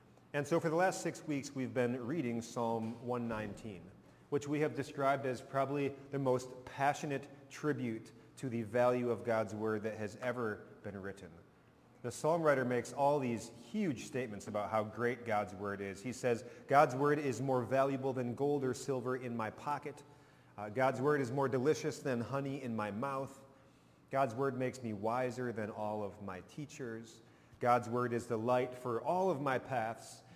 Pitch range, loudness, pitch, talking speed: 115-140 Hz, -37 LUFS, 125 Hz, 180 wpm